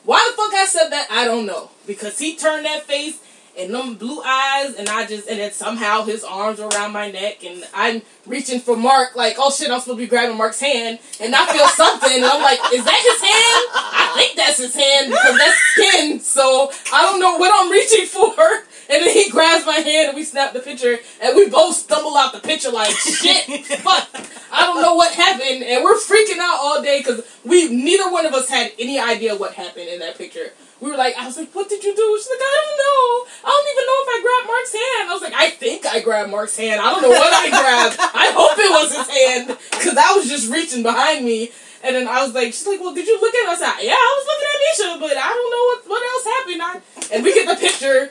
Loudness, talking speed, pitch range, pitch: -15 LUFS, 255 wpm, 250-390 Hz, 295 Hz